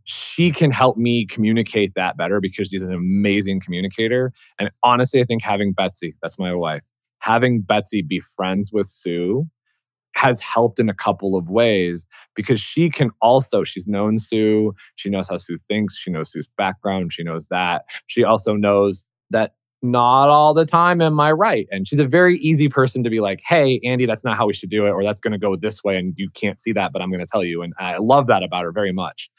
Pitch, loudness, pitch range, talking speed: 105 Hz, -19 LUFS, 95-125 Hz, 220 wpm